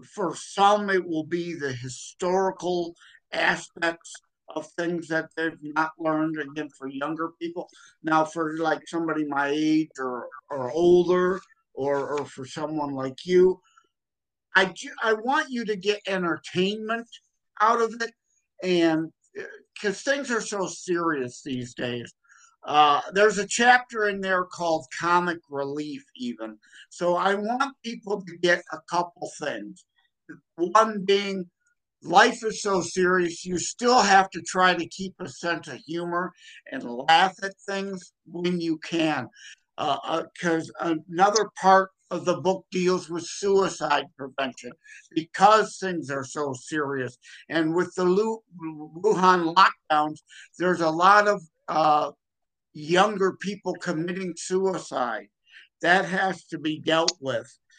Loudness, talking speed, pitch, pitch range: -25 LUFS, 140 wpm, 175 Hz, 155-195 Hz